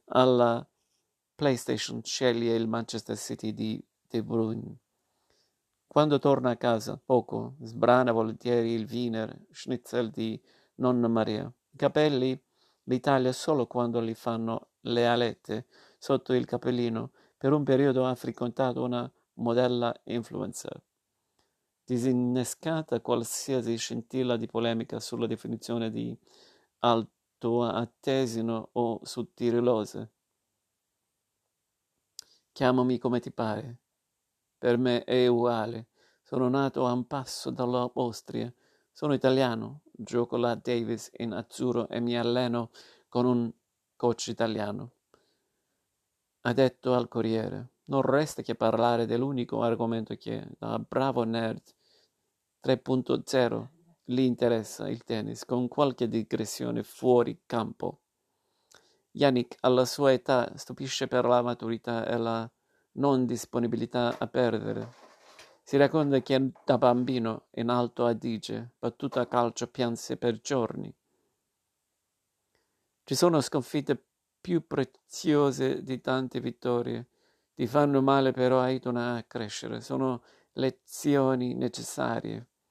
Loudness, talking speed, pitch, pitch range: -29 LUFS, 110 wpm, 120 Hz, 115-130 Hz